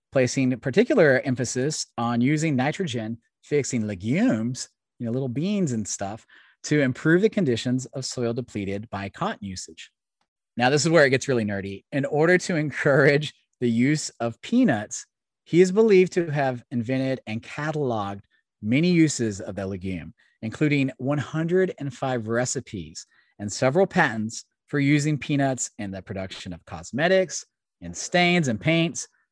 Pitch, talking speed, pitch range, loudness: 130 Hz, 145 wpm, 115-155 Hz, -24 LUFS